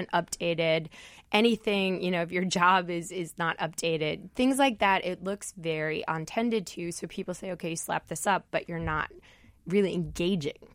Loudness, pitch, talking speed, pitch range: -29 LUFS, 180 Hz, 180 wpm, 165-195 Hz